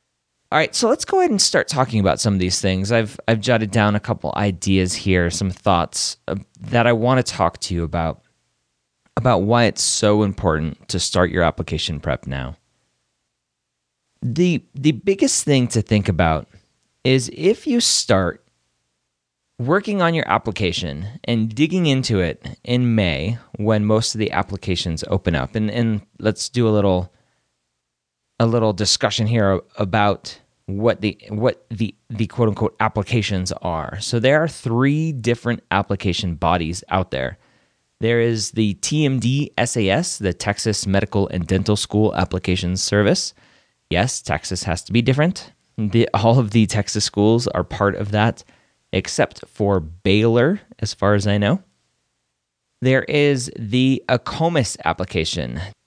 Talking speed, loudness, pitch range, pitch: 150 wpm, -19 LUFS, 90-120 Hz, 105 Hz